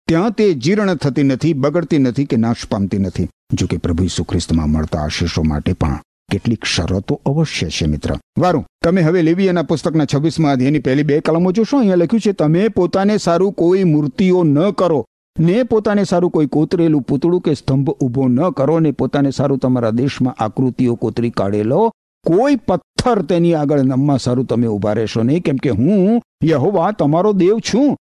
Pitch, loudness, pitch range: 145 Hz, -16 LUFS, 120-180 Hz